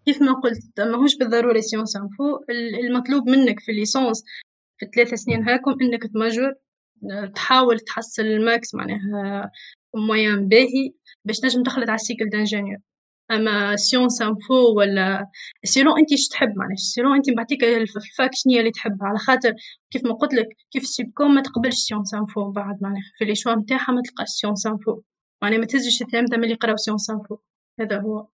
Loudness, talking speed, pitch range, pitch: -20 LUFS, 165 wpm, 210-255 Hz, 230 Hz